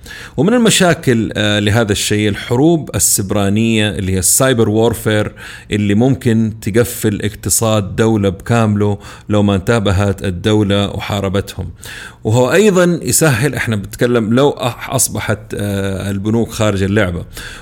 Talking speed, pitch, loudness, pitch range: 105 wpm, 110 Hz, -14 LUFS, 100-120 Hz